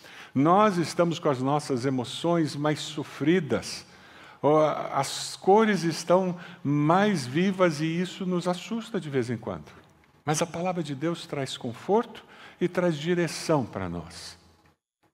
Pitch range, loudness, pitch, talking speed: 140-180 Hz, -26 LUFS, 165 Hz, 130 wpm